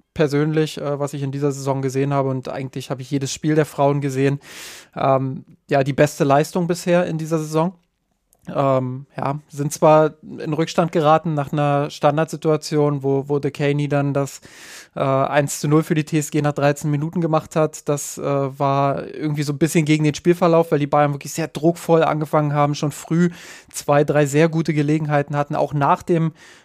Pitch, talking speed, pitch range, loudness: 150 Hz, 185 wpm, 140-160 Hz, -20 LUFS